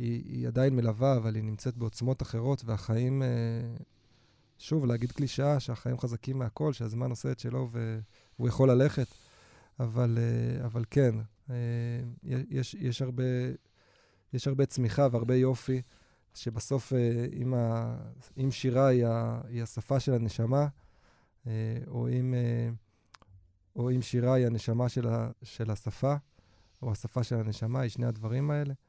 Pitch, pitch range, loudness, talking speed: 120 Hz, 115-130 Hz, -31 LUFS, 120 wpm